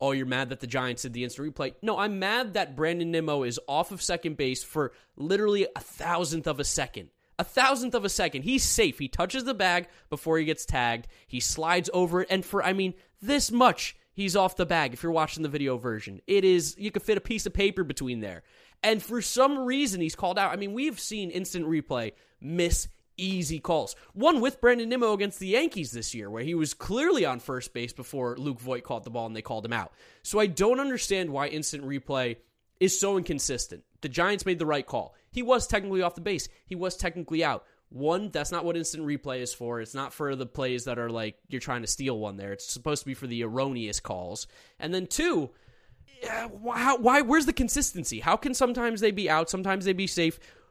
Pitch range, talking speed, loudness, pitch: 130-200 Hz, 225 wpm, -28 LUFS, 165 Hz